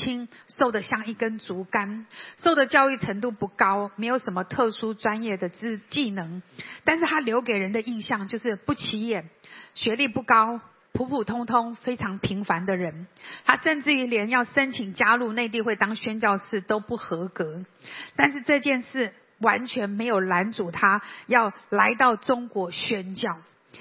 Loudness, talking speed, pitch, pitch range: -24 LUFS, 240 characters per minute, 225 Hz, 200-245 Hz